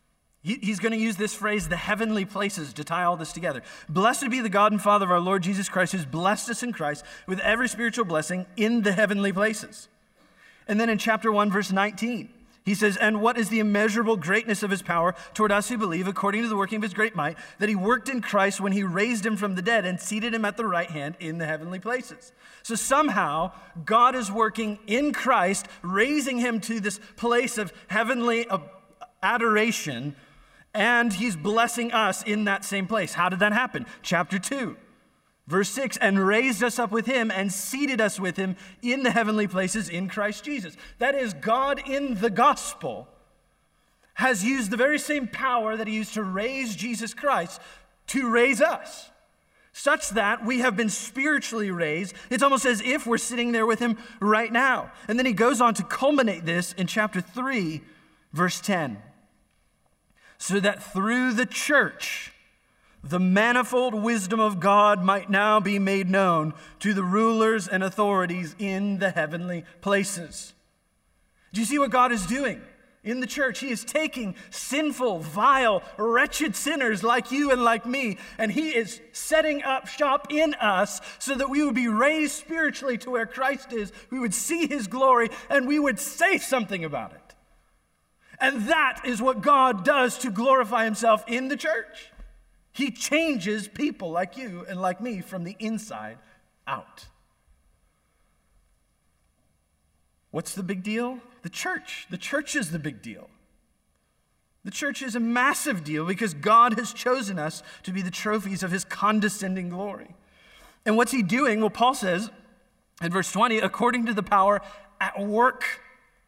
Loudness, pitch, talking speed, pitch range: -25 LUFS, 220 Hz, 175 wpm, 190-245 Hz